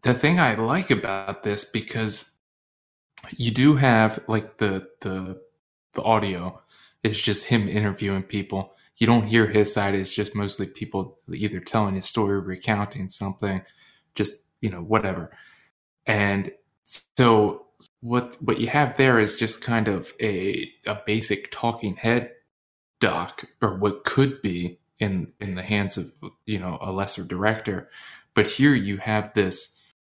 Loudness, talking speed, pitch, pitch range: -24 LUFS, 150 wpm, 105 Hz, 95-115 Hz